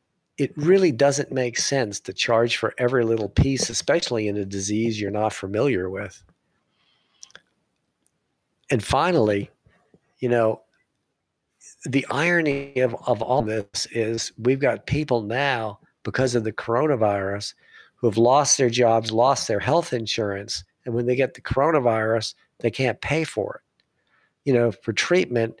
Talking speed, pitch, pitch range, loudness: 145 wpm, 120 Hz, 110-135 Hz, -22 LUFS